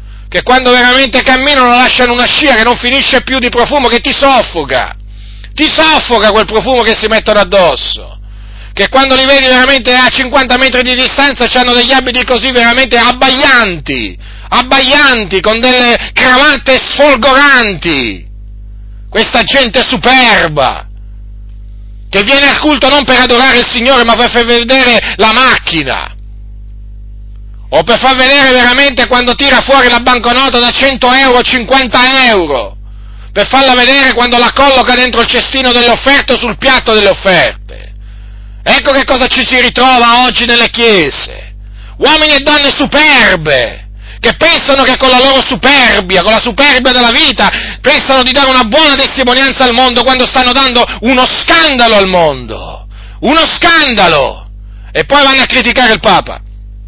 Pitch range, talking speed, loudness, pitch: 215-265 Hz, 150 wpm, -5 LUFS, 250 Hz